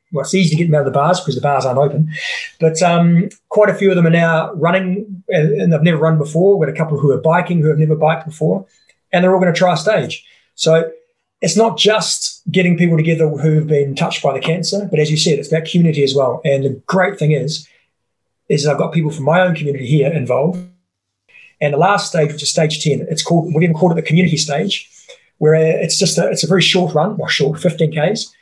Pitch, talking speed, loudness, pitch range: 165 Hz, 250 wpm, -15 LUFS, 150-185 Hz